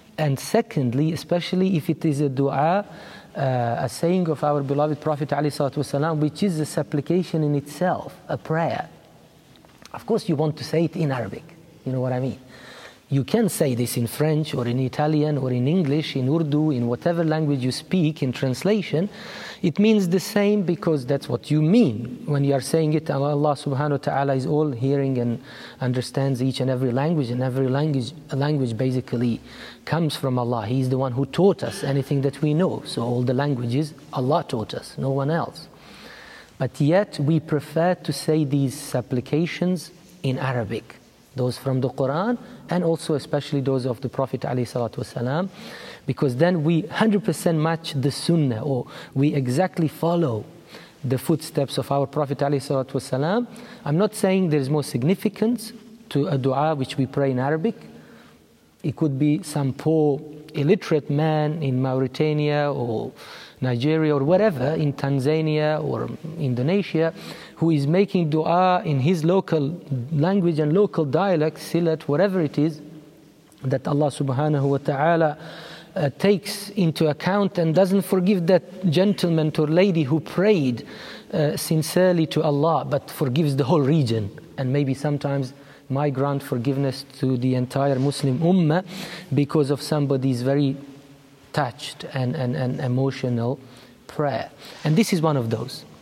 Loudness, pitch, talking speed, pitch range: -23 LUFS, 150 Hz, 155 wpm, 135-165 Hz